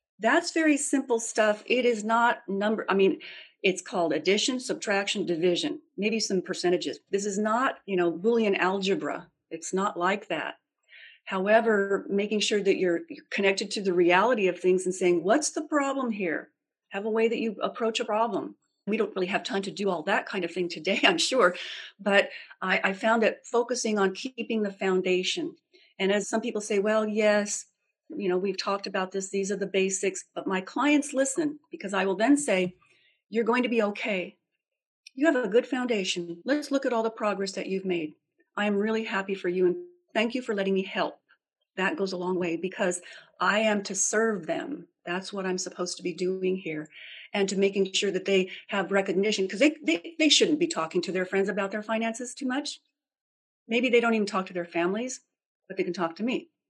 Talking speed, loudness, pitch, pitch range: 205 wpm, -27 LUFS, 205 Hz, 185-235 Hz